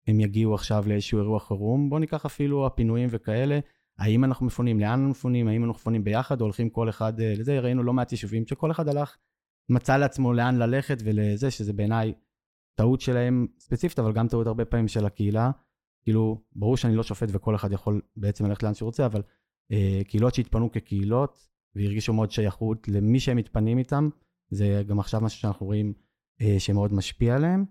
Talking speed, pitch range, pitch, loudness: 180 wpm, 105-125 Hz, 115 Hz, -26 LUFS